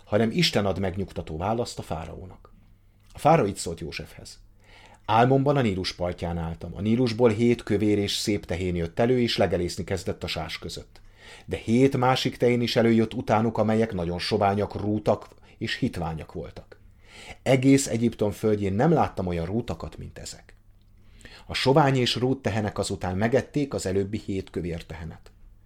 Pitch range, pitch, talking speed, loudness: 95-115 Hz, 100 Hz, 155 wpm, -25 LUFS